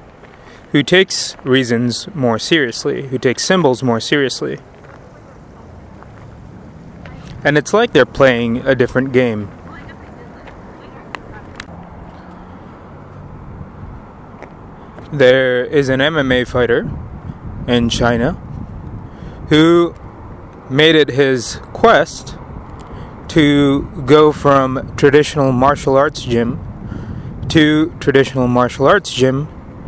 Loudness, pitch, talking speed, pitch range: -14 LUFS, 130 Hz, 85 wpm, 120-145 Hz